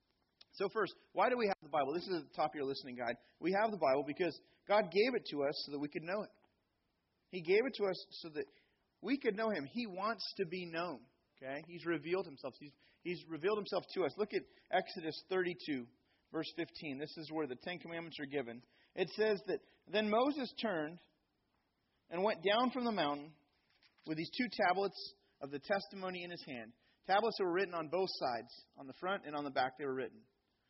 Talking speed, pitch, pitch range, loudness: 220 wpm, 175 Hz, 145-205 Hz, -39 LUFS